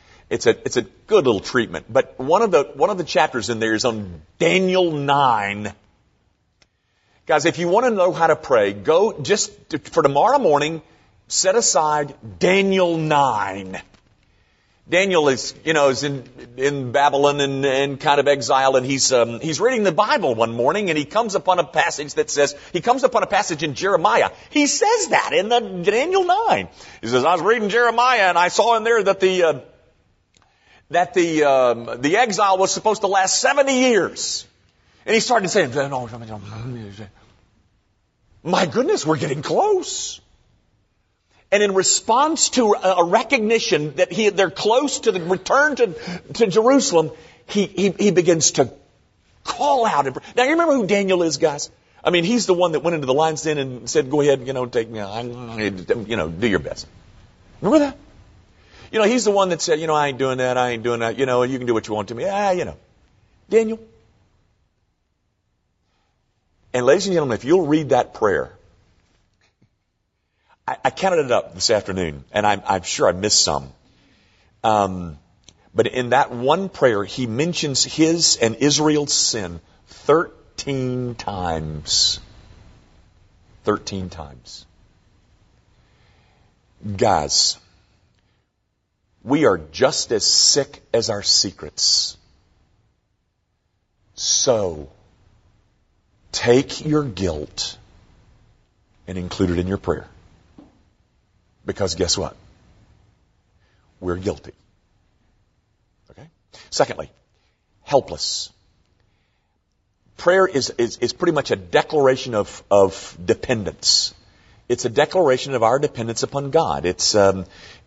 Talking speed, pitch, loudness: 150 wpm, 130 Hz, -19 LUFS